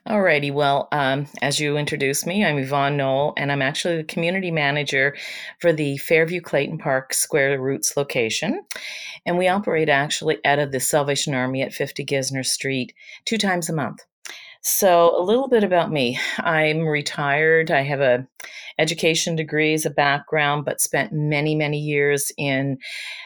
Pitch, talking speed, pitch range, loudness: 150 Hz, 165 wpm, 140-165 Hz, -21 LUFS